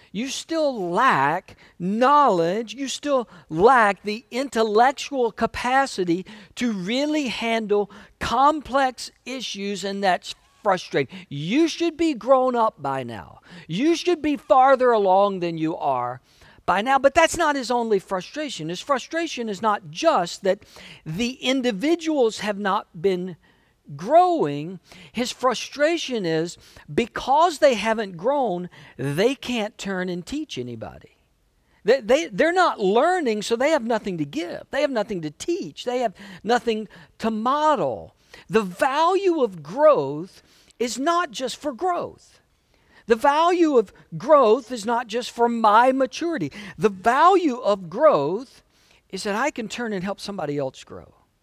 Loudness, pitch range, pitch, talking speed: -22 LUFS, 190-280 Hz, 230 Hz, 140 wpm